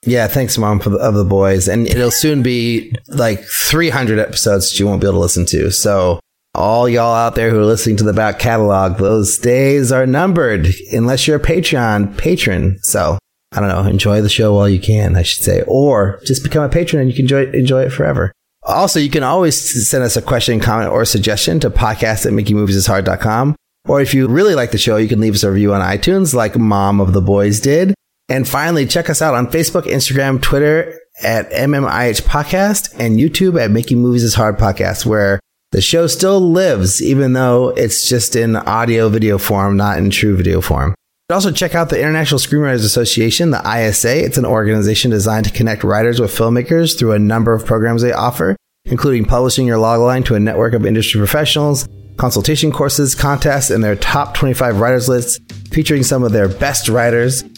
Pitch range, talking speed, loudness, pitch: 105-135 Hz, 200 wpm, -13 LUFS, 115 Hz